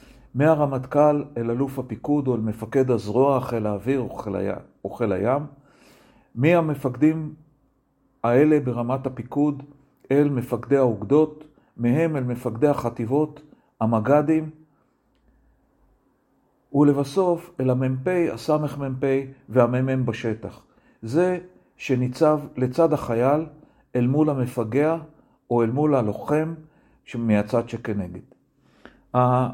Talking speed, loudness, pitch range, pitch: 90 wpm, -23 LUFS, 120-150 Hz, 135 Hz